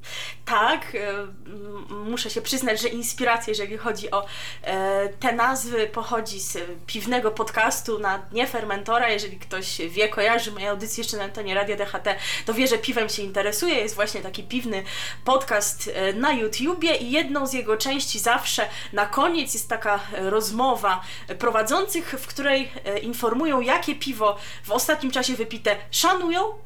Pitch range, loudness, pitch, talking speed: 205-255 Hz, -24 LUFS, 220 Hz, 145 wpm